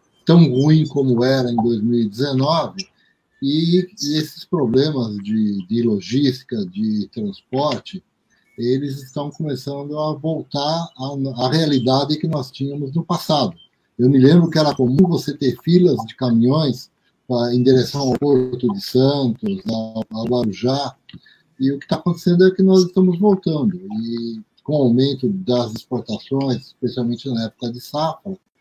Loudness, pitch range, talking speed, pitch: -19 LUFS, 125-165 Hz, 140 wpm, 140 Hz